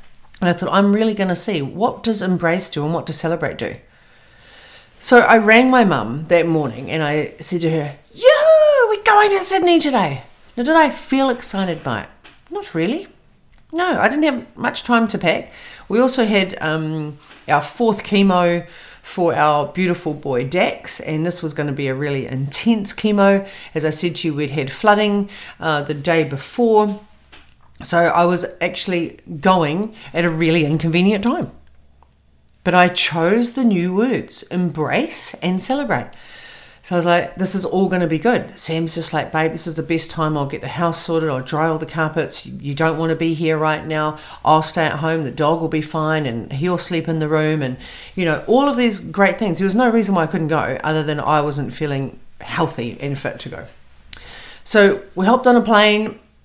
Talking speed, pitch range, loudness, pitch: 200 wpm, 155-210 Hz, -17 LUFS, 170 Hz